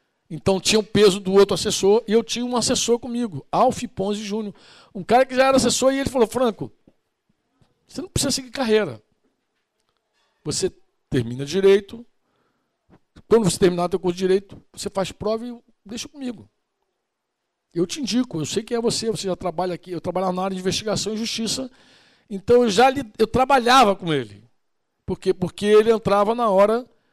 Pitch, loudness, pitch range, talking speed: 210 Hz, -20 LUFS, 185-240 Hz, 185 wpm